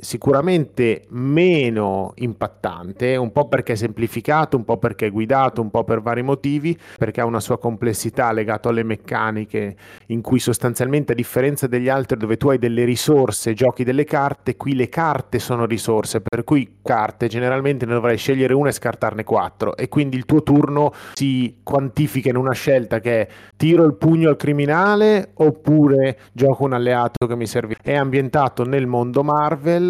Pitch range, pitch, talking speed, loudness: 115-140 Hz, 125 Hz, 175 wpm, -19 LUFS